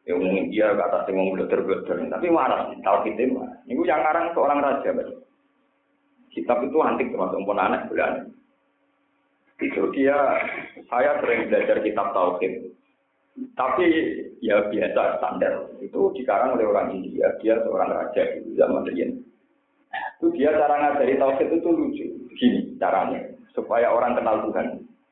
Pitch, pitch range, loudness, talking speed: 280 Hz, 250-330 Hz, -23 LUFS, 145 wpm